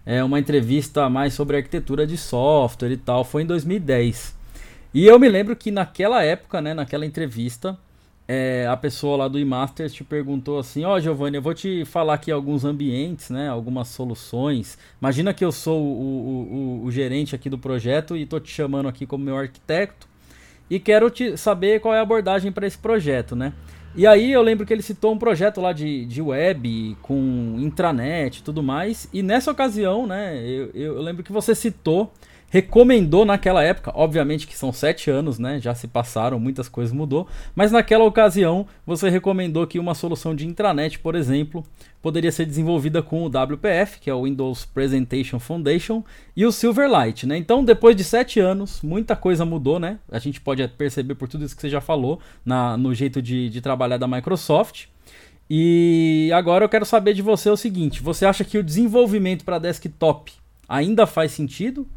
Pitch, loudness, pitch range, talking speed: 155 Hz, -20 LUFS, 135-190 Hz, 190 wpm